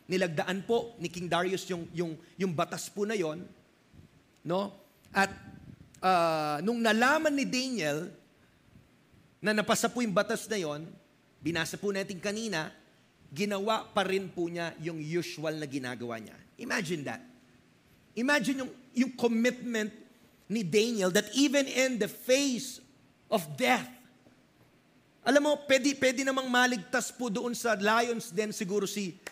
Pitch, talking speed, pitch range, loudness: 210 Hz, 140 wpm, 175-245 Hz, -30 LUFS